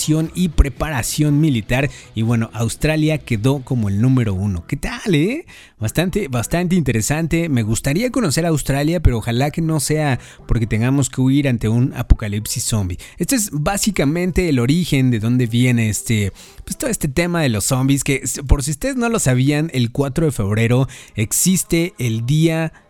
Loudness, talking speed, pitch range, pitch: -18 LUFS, 170 wpm, 120-160 Hz, 135 Hz